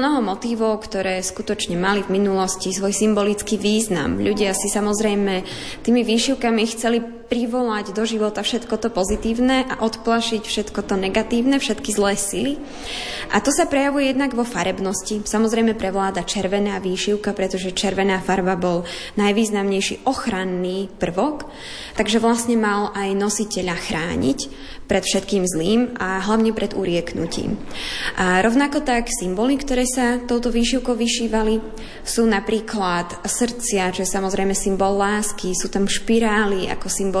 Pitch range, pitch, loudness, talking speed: 195-230 Hz, 210 Hz, -20 LUFS, 135 wpm